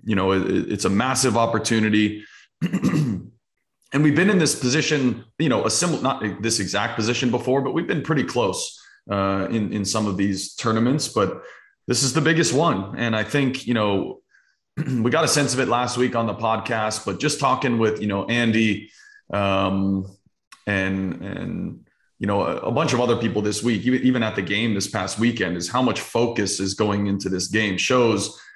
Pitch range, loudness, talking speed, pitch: 100-125 Hz, -22 LUFS, 195 wpm, 115 Hz